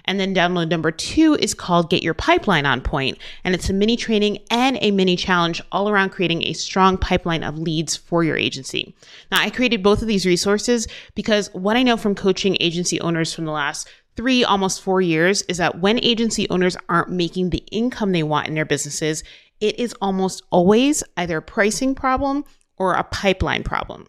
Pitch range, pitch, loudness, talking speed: 170-215 Hz, 190 Hz, -19 LUFS, 200 wpm